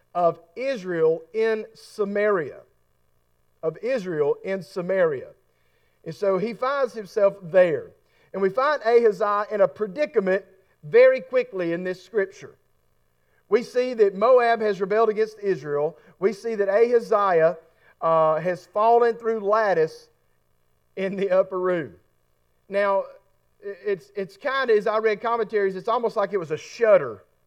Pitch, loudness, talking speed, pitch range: 200 Hz, -23 LUFS, 140 wpm, 170-225 Hz